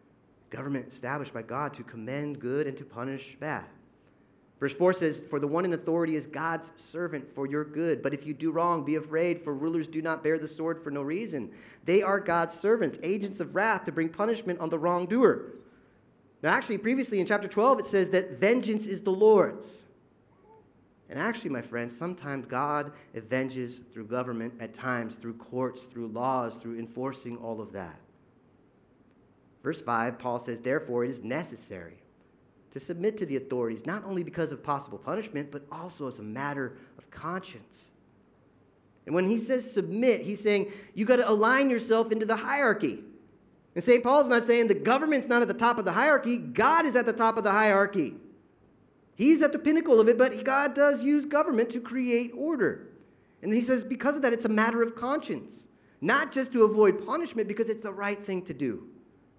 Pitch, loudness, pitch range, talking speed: 175 Hz, -28 LUFS, 135-225 Hz, 190 wpm